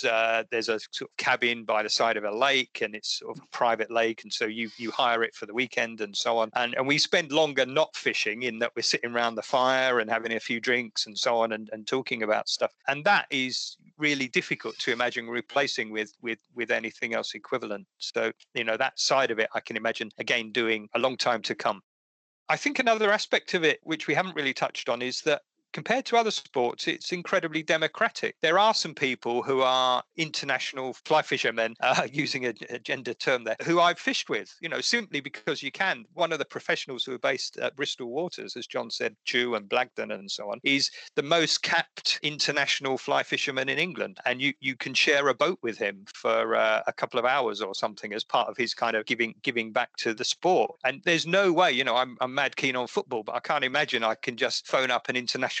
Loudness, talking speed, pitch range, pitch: -27 LUFS, 230 wpm, 115-155 Hz, 130 Hz